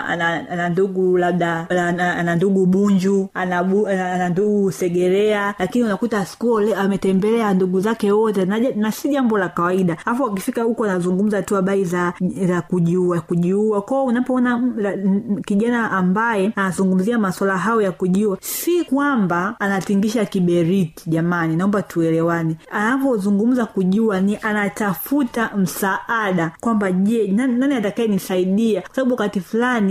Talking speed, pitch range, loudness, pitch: 110 wpm, 185-220 Hz, -19 LUFS, 195 Hz